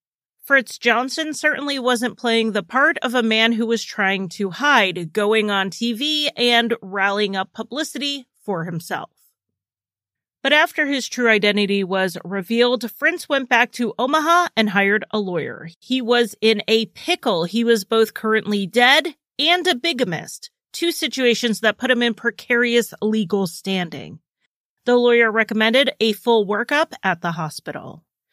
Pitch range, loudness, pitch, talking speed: 205-265 Hz, -19 LUFS, 230 Hz, 150 wpm